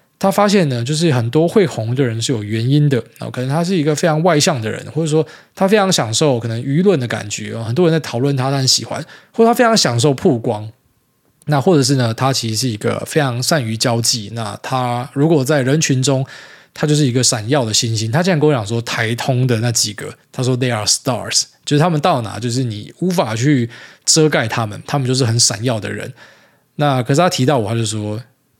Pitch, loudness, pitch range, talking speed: 130 Hz, -16 LUFS, 115-155 Hz, 340 characters per minute